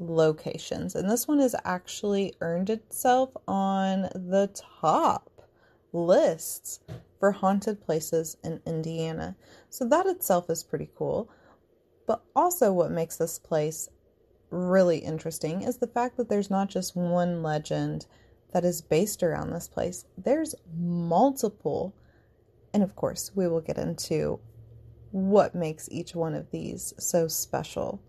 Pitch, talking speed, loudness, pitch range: 180 Hz, 135 wpm, -28 LUFS, 165-205 Hz